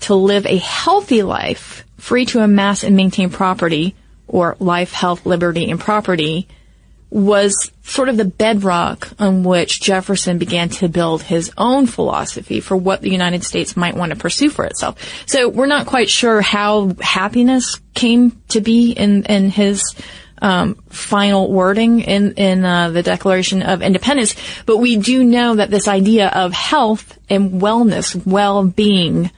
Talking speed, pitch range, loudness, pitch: 155 wpm, 185-220 Hz, -15 LUFS, 200 Hz